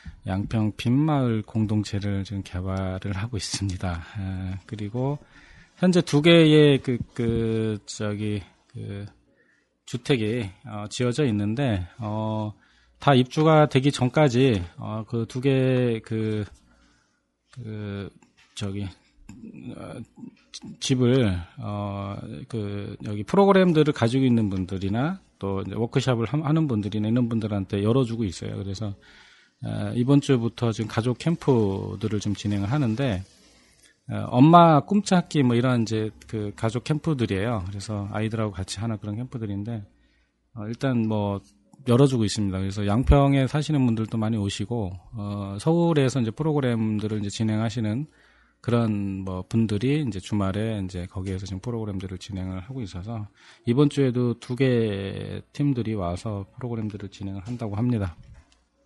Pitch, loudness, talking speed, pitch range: 110 Hz, -24 LUFS, 285 characters per minute, 100-125 Hz